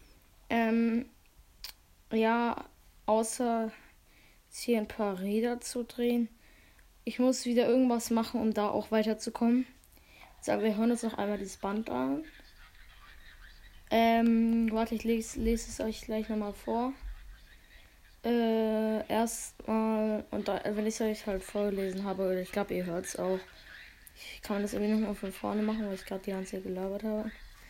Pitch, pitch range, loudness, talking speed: 220 Hz, 200-230 Hz, -32 LUFS, 165 wpm